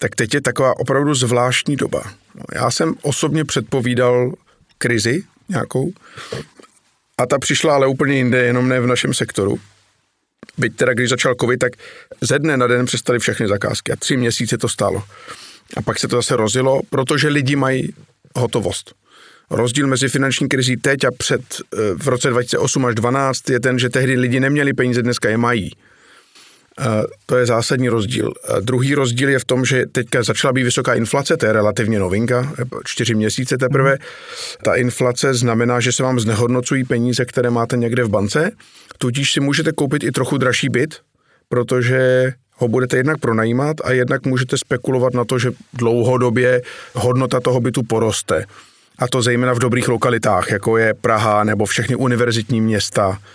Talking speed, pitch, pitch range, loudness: 165 wpm, 125 Hz, 120-135 Hz, -17 LUFS